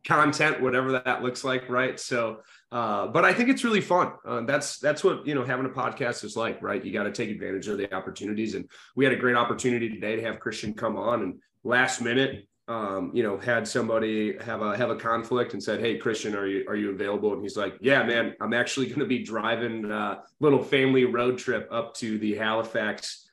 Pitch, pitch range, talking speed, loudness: 120 Hz, 110-130 Hz, 225 wpm, -26 LUFS